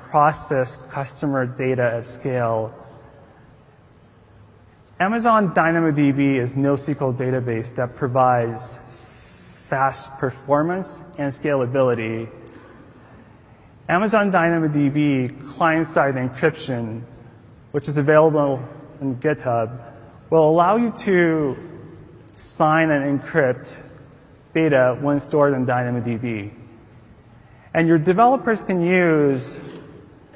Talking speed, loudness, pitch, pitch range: 85 wpm, -20 LUFS, 135 Hz, 120-155 Hz